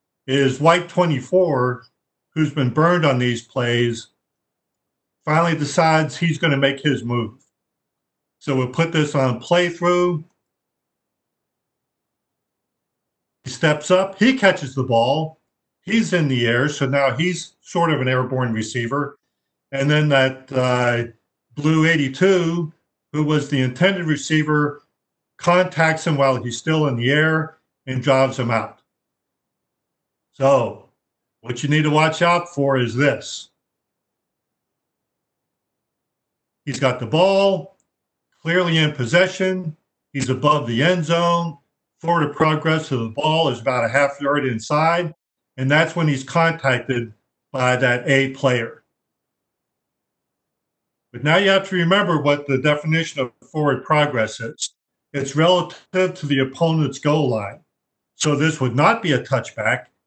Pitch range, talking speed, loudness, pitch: 130-165 Hz, 135 wpm, -19 LUFS, 150 Hz